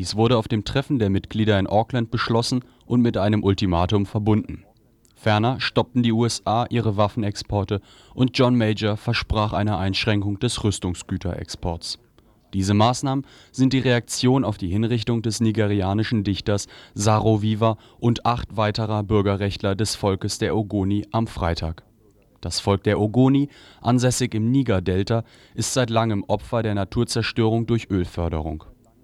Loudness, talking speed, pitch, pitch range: -22 LUFS, 140 wpm, 110 Hz, 100-120 Hz